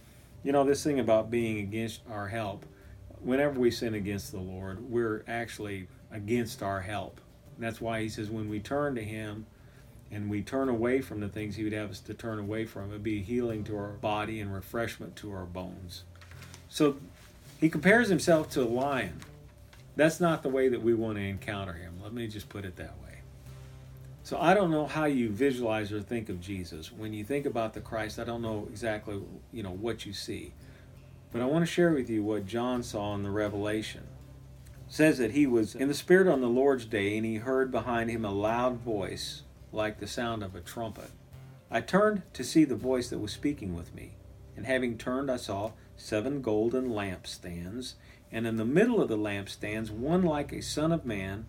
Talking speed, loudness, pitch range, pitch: 205 wpm, -31 LUFS, 100-125 Hz, 110 Hz